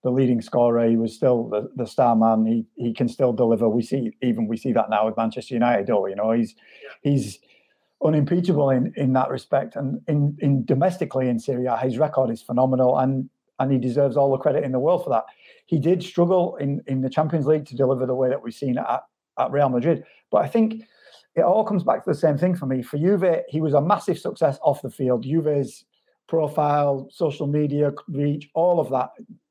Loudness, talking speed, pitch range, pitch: -22 LUFS, 220 wpm, 125-155 Hz, 135 Hz